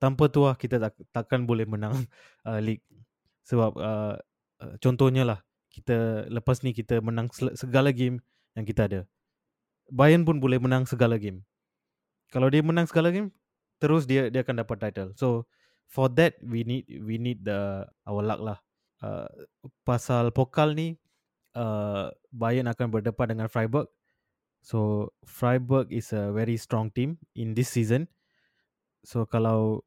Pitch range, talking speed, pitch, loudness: 110-130 Hz, 150 wpm, 120 Hz, -27 LUFS